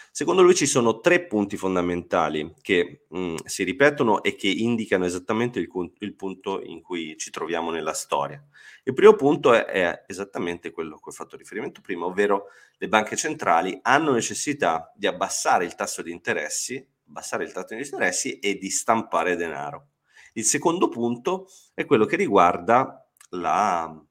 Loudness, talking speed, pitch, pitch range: -23 LUFS, 160 wpm, 100 Hz, 90-120 Hz